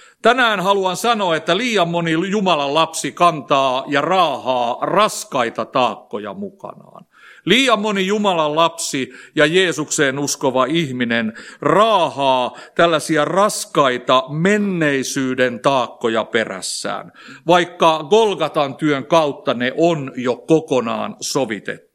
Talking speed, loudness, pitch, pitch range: 100 wpm, -17 LUFS, 155 Hz, 135-180 Hz